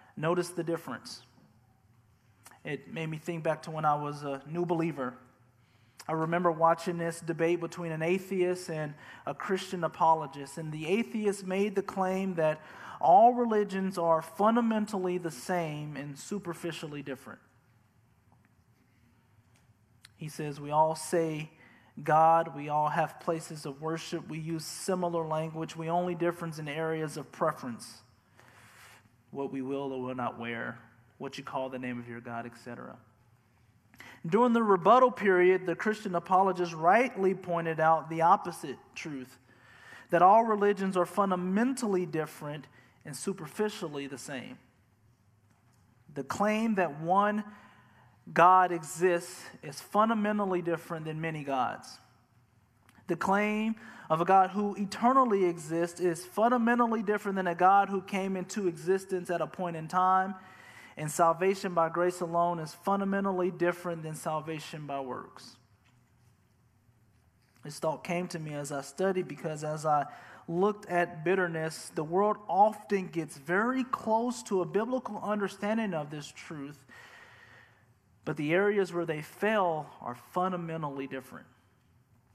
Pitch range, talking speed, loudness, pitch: 130-185 Hz, 135 wpm, -30 LUFS, 165 Hz